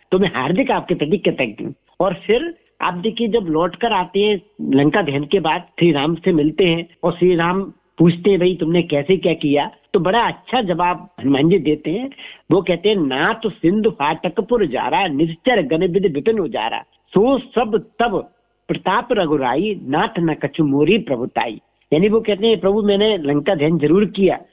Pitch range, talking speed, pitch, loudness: 160-210 Hz, 175 wpm, 180 Hz, -18 LUFS